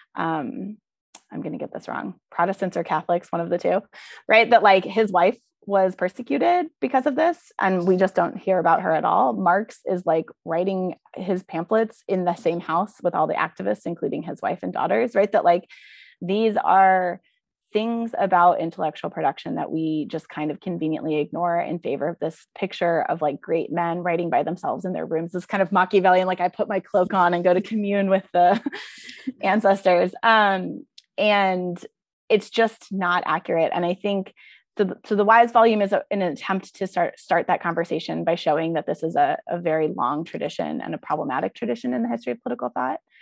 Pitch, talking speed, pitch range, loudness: 185 Hz, 195 wpm, 170-205 Hz, -22 LUFS